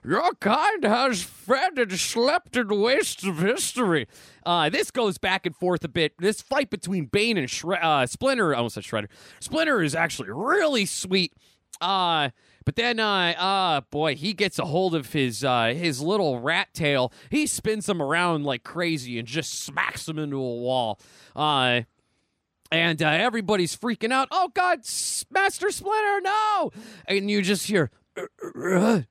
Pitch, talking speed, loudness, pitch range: 185 Hz, 165 wpm, -24 LUFS, 150-225 Hz